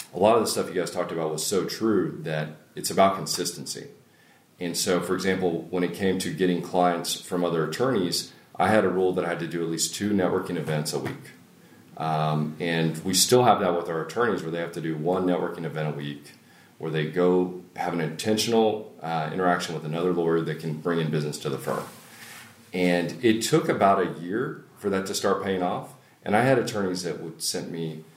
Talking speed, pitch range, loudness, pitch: 220 wpm, 80-95 Hz, -26 LUFS, 85 Hz